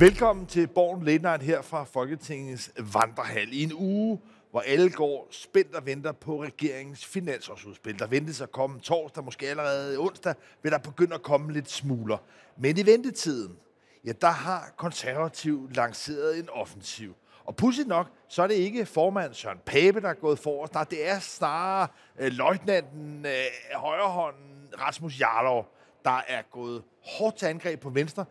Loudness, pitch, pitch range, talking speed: -28 LUFS, 150 Hz, 135-175 Hz, 165 wpm